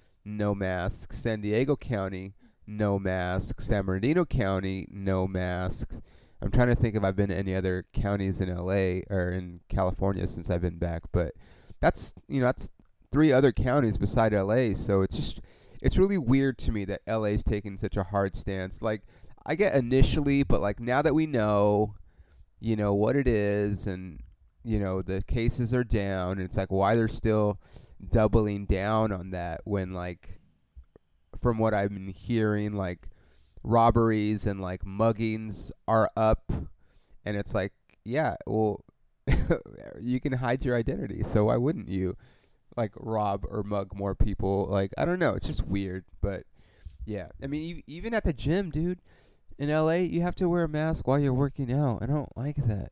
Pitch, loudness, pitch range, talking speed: 105 Hz, -28 LUFS, 95-120 Hz, 175 wpm